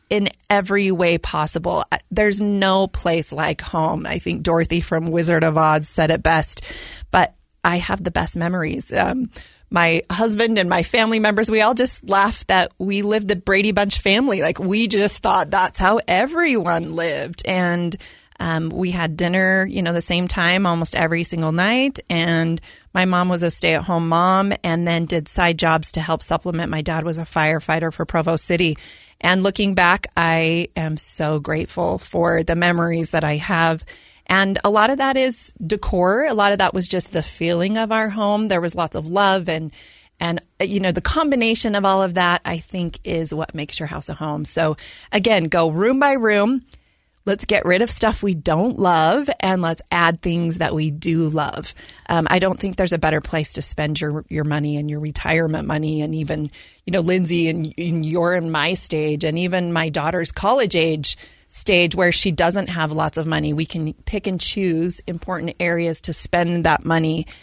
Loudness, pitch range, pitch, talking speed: -18 LUFS, 160-195 Hz, 170 Hz, 195 wpm